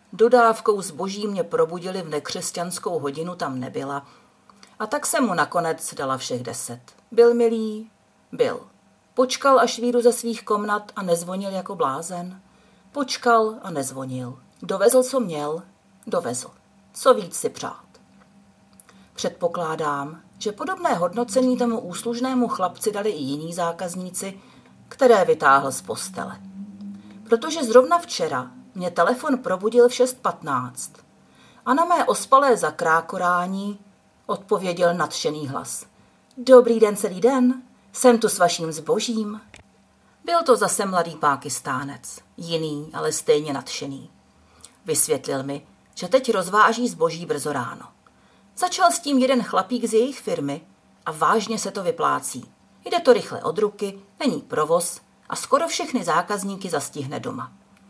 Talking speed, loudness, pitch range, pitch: 130 wpm, -22 LUFS, 175-245 Hz, 205 Hz